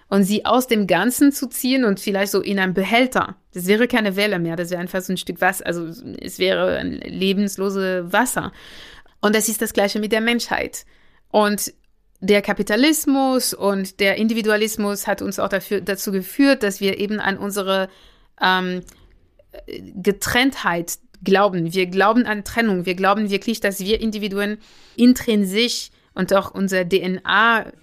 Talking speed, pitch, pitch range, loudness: 160 wpm, 205 Hz, 190-225 Hz, -19 LUFS